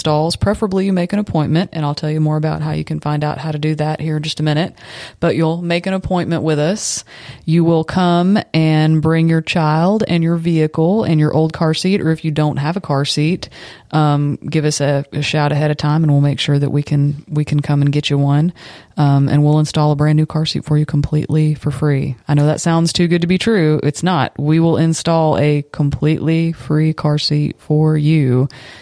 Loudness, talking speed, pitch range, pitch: -16 LUFS, 235 wpm, 150-165 Hz, 155 Hz